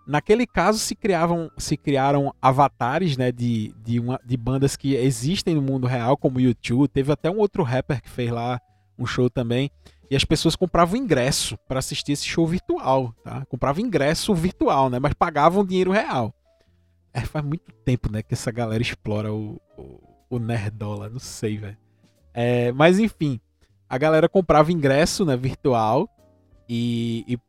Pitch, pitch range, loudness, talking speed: 130 Hz, 115-155 Hz, -22 LUFS, 170 wpm